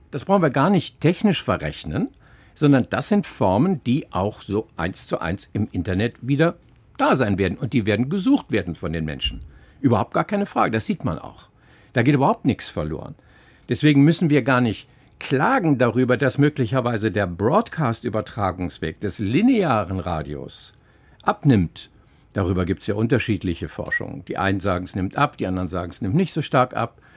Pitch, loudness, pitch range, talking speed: 115 Hz, -22 LUFS, 95-145 Hz, 175 wpm